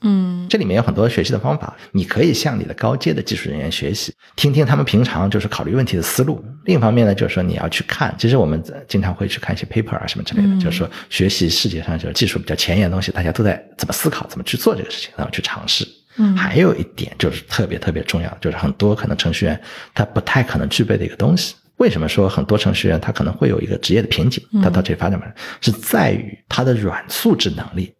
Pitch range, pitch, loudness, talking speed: 95-140 Hz, 105 Hz, -18 LUFS, 400 characters per minute